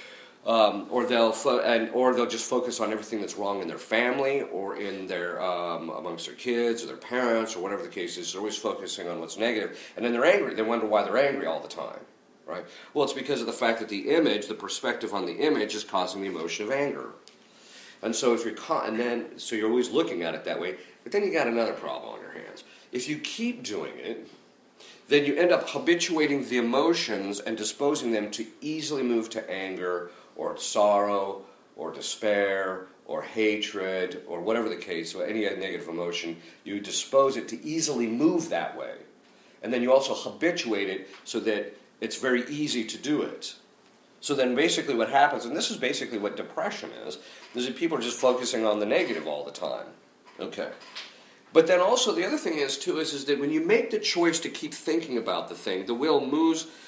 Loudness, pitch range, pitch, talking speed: -27 LUFS, 105-155 Hz, 120 Hz, 215 wpm